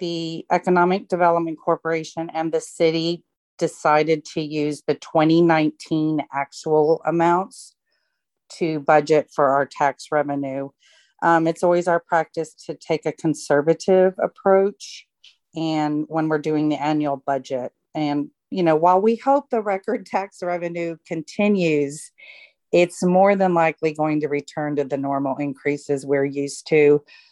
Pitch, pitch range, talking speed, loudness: 160 Hz, 150-175 Hz, 135 wpm, -21 LUFS